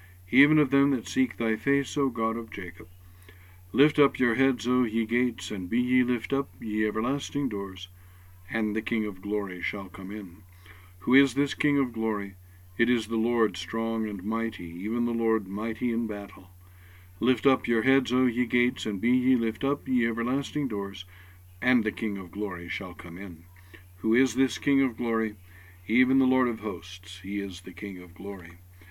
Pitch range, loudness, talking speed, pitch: 90-125 Hz, -27 LUFS, 195 wpm, 110 Hz